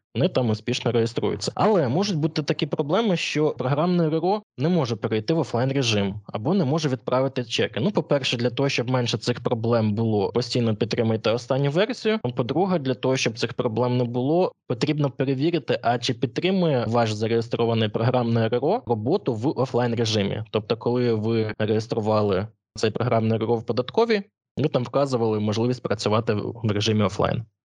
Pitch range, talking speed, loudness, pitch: 115-150 Hz, 160 wpm, -23 LUFS, 125 Hz